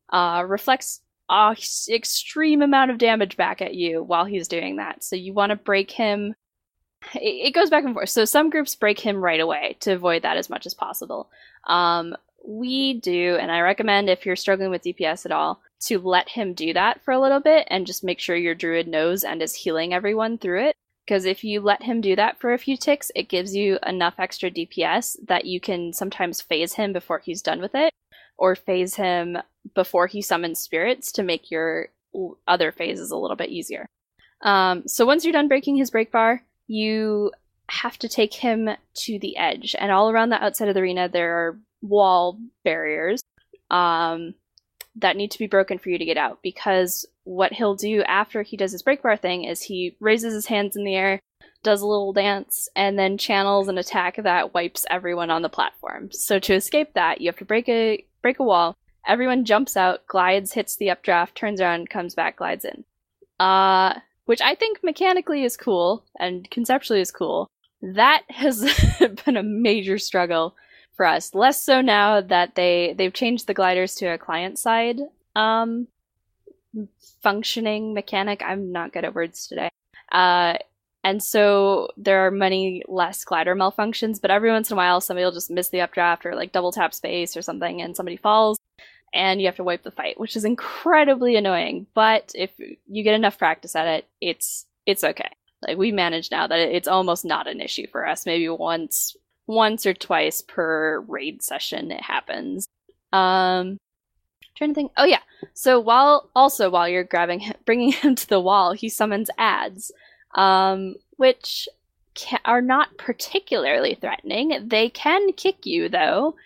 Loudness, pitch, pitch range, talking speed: -21 LUFS, 200 Hz, 180-230 Hz, 190 wpm